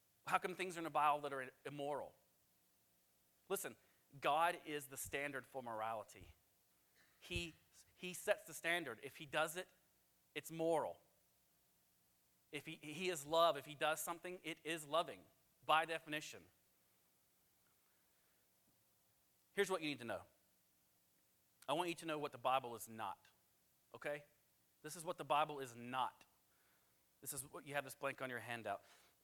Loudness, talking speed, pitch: -43 LUFS, 155 wpm, 135 Hz